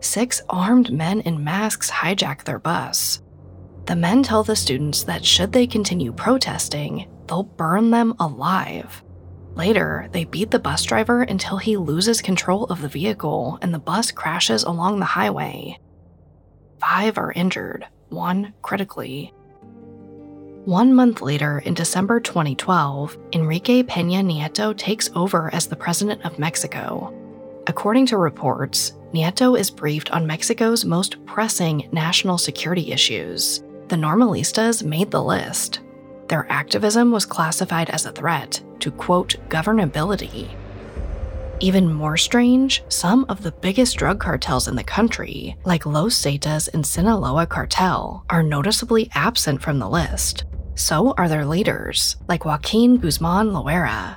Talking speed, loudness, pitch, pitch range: 135 wpm, -20 LUFS, 170 Hz, 145-210 Hz